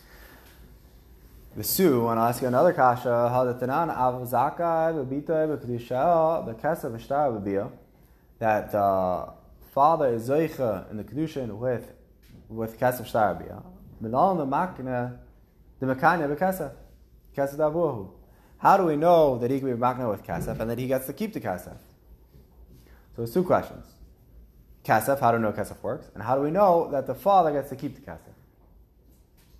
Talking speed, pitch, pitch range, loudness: 170 wpm, 125 Hz, 100-145 Hz, -25 LUFS